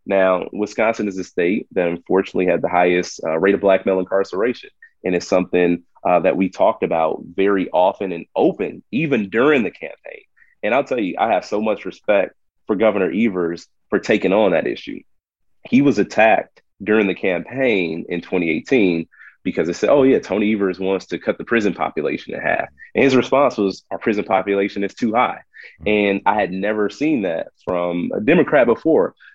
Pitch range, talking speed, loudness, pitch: 90-105 Hz, 190 wpm, -19 LUFS, 95 Hz